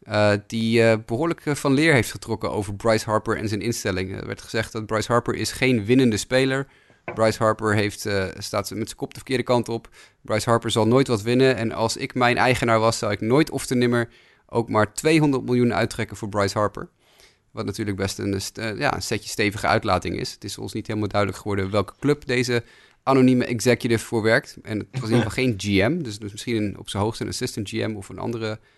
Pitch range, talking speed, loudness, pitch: 105-125 Hz, 230 wpm, -23 LUFS, 115 Hz